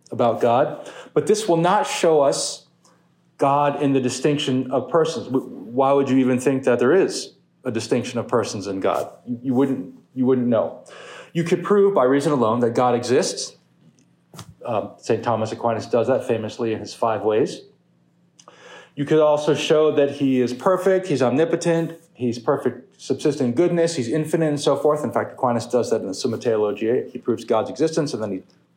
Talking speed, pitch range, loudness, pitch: 185 wpm, 125-160 Hz, -21 LUFS, 135 Hz